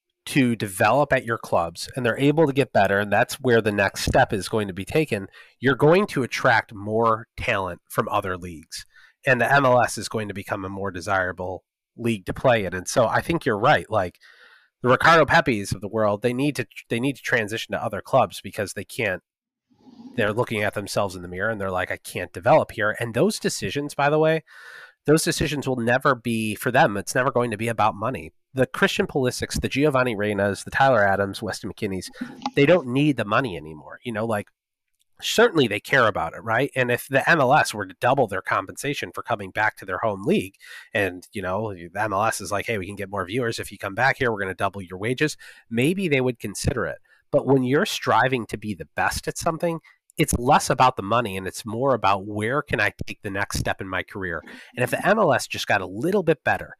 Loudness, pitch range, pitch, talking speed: -23 LUFS, 100-140 Hz, 115 Hz, 225 wpm